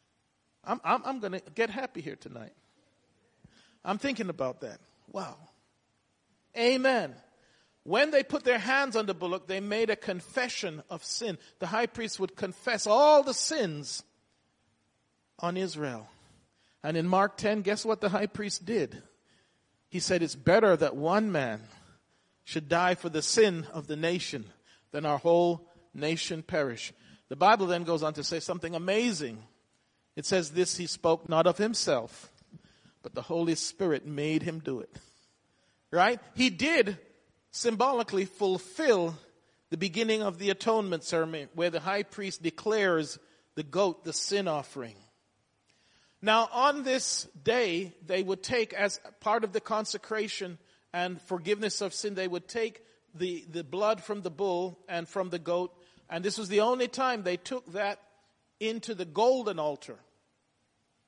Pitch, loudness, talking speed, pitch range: 185 Hz, -30 LUFS, 155 wpm, 165-215 Hz